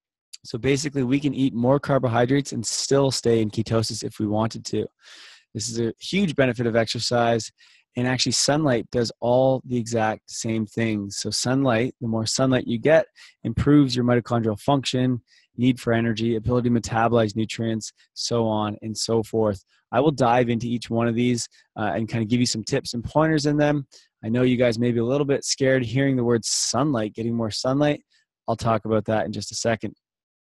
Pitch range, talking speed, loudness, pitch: 115-130 Hz, 195 wpm, -23 LUFS, 120 Hz